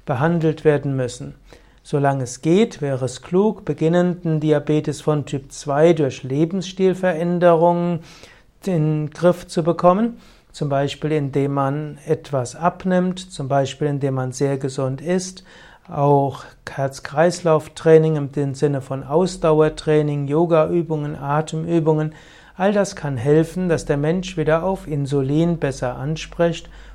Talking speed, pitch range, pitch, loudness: 120 wpm, 140-170 Hz, 155 Hz, -20 LUFS